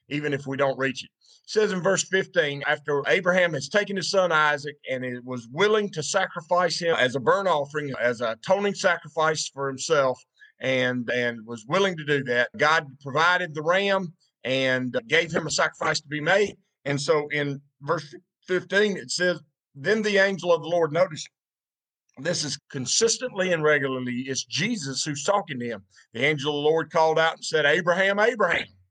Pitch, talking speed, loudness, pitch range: 155 Hz, 185 wpm, -24 LUFS, 135-180 Hz